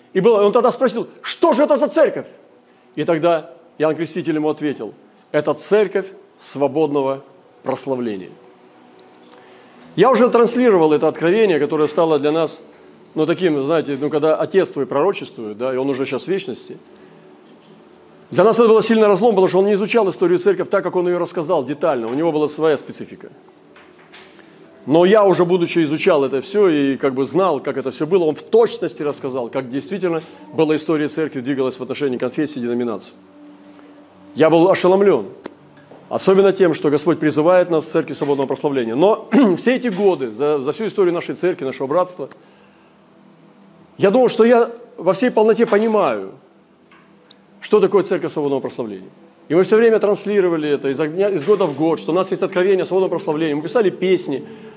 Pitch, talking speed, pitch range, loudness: 165 Hz, 170 wpm, 145-200 Hz, -17 LUFS